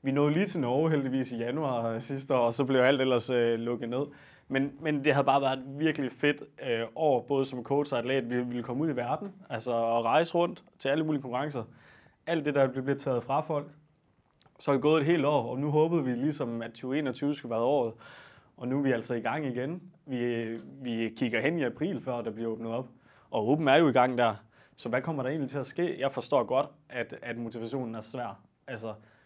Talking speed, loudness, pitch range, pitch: 240 wpm, -30 LUFS, 120-145 Hz, 130 Hz